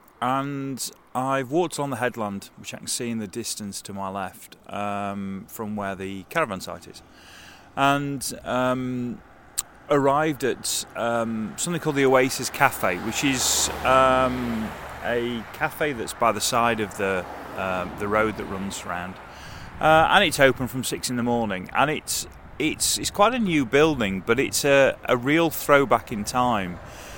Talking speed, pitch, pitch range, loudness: 165 wpm, 125 Hz, 105-140 Hz, -23 LUFS